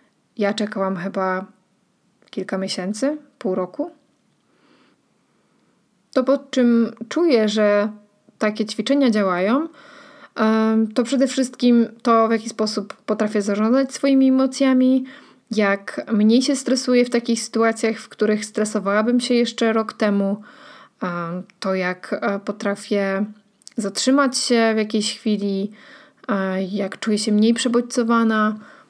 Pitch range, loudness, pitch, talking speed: 205-255 Hz, -20 LUFS, 220 Hz, 110 wpm